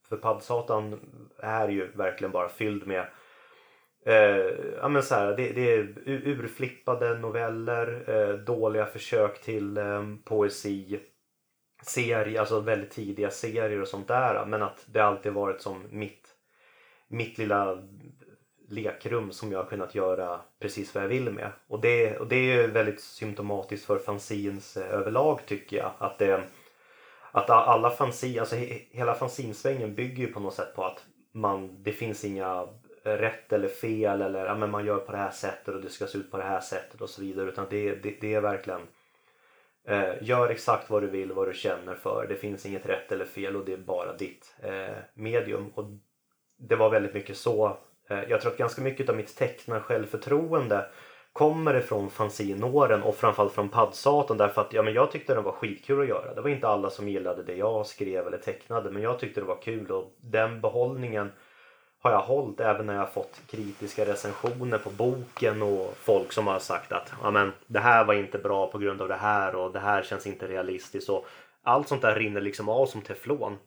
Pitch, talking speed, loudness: 110 Hz, 190 wpm, -28 LUFS